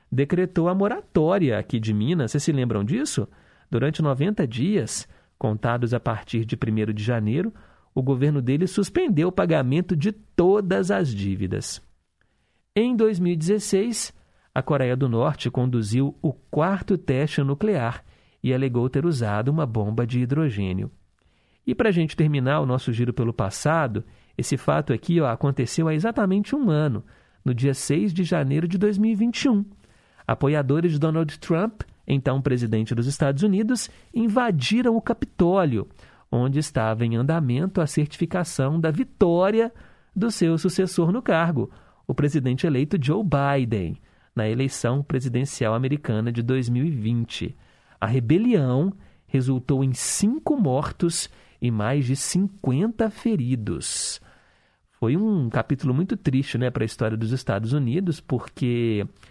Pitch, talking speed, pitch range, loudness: 140 Hz, 135 wpm, 120-180 Hz, -23 LUFS